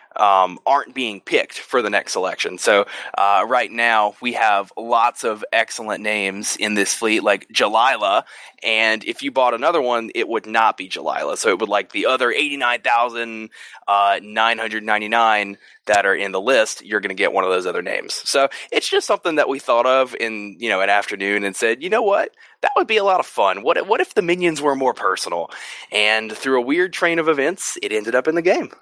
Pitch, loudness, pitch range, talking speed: 120 Hz, -19 LUFS, 105-175 Hz, 215 wpm